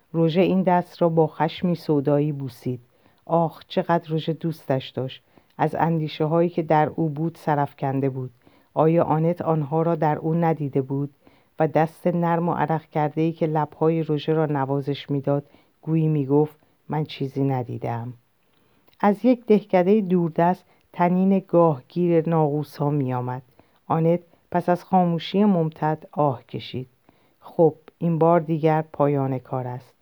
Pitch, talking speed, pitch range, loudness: 155 Hz, 140 wpm, 140-170 Hz, -23 LUFS